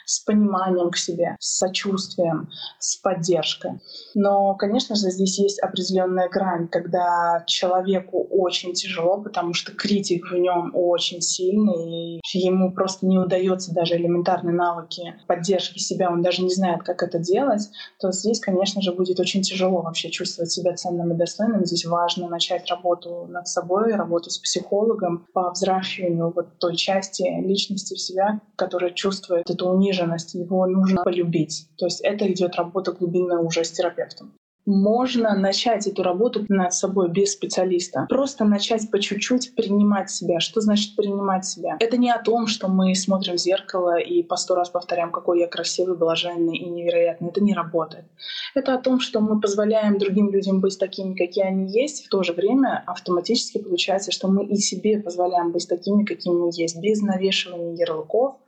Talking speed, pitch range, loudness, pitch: 165 wpm, 175-200 Hz, -22 LUFS, 185 Hz